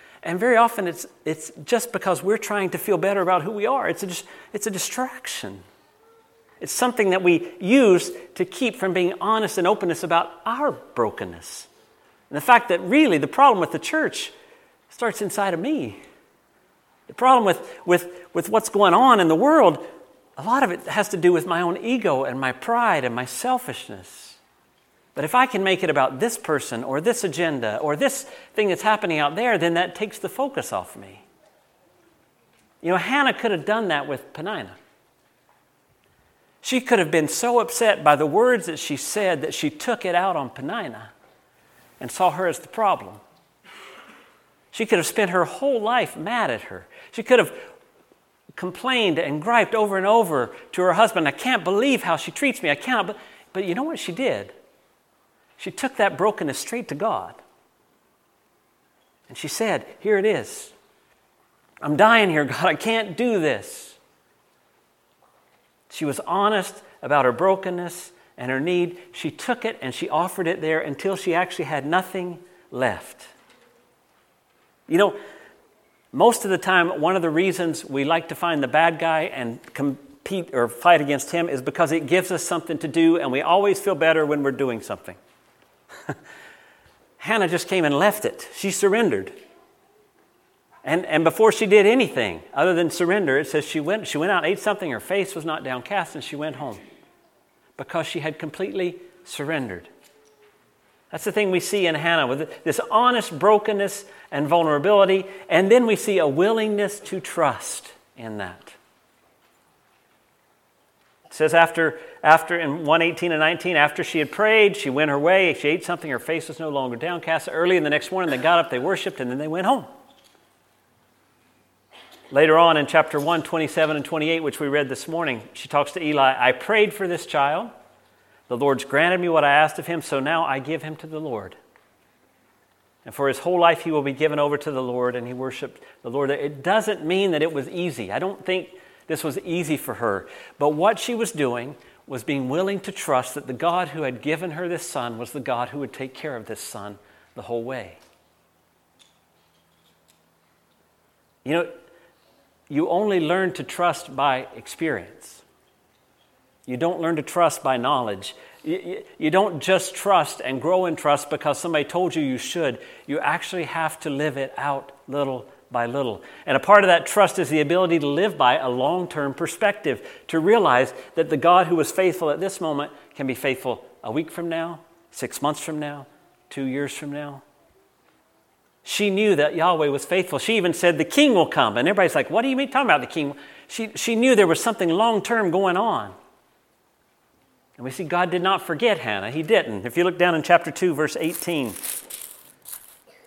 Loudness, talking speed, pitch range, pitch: -22 LUFS, 185 wpm, 150-210 Hz, 175 Hz